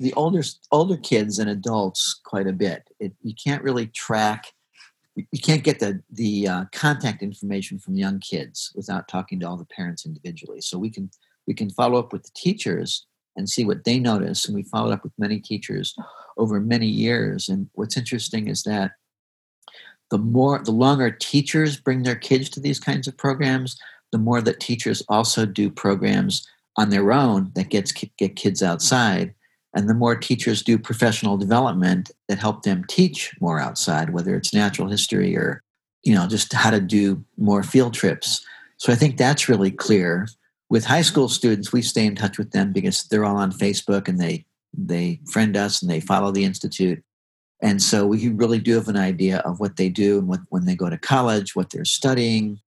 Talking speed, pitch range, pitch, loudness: 195 wpm, 100-135 Hz, 110 Hz, -21 LUFS